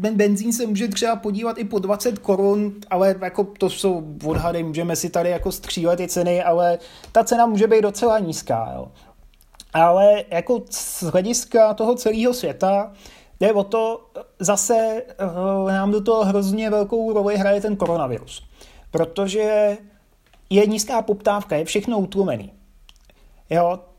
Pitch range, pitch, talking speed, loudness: 180-215 Hz, 200 Hz, 145 wpm, -20 LUFS